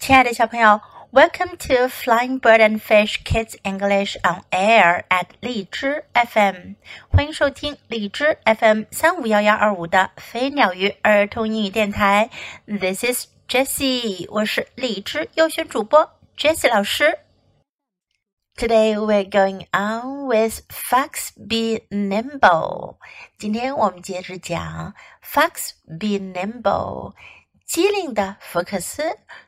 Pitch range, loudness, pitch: 200-260 Hz, -19 LUFS, 220 Hz